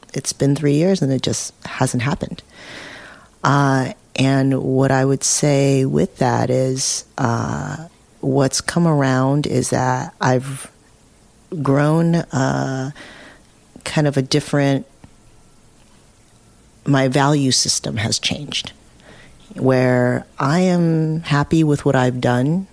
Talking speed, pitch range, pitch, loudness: 115 wpm, 130-150 Hz, 135 Hz, -18 LUFS